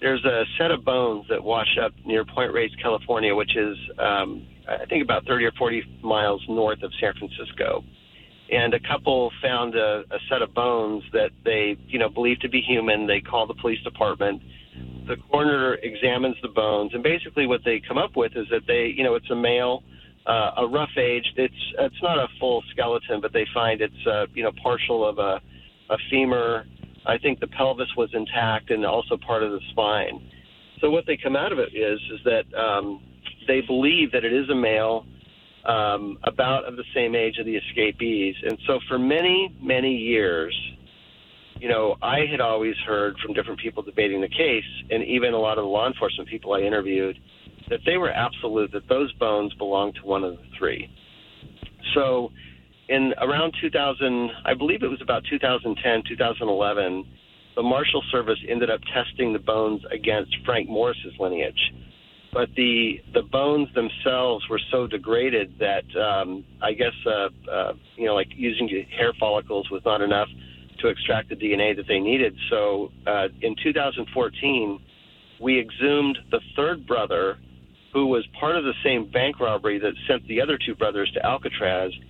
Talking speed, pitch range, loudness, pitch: 180 wpm, 100-130 Hz, -24 LUFS, 115 Hz